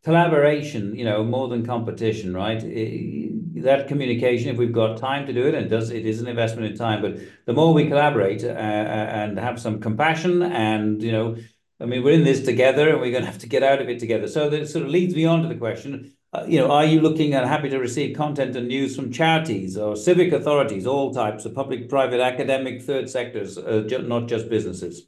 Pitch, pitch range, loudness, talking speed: 125 Hz, 110-145 Hz, -22 LUFS, 210 wpm